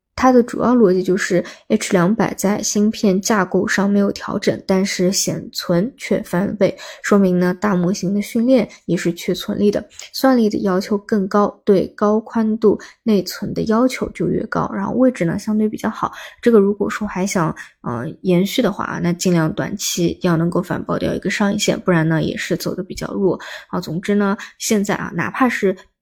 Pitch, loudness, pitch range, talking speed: 200 Hz, -18 LUFS, 180-215 Hz, 280 characters per minute